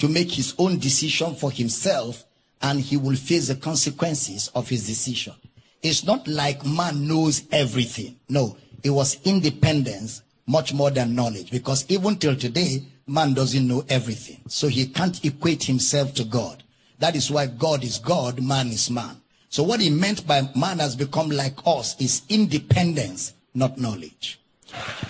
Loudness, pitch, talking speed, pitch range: -22 LUFS, 140 Hz, 165 wpm, 125-155 Hz